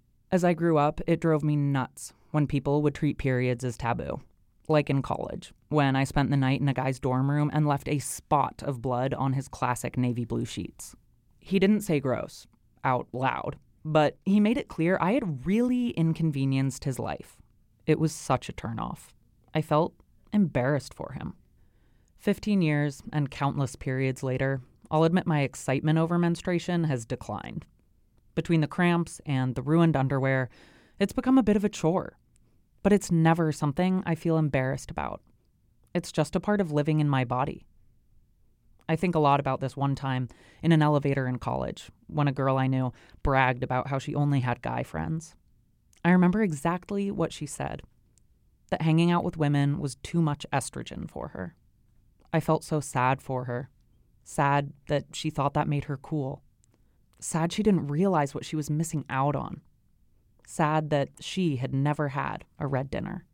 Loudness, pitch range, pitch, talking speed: -28 LUFS, 130-165 Hz, 145 Hz, 180 wpm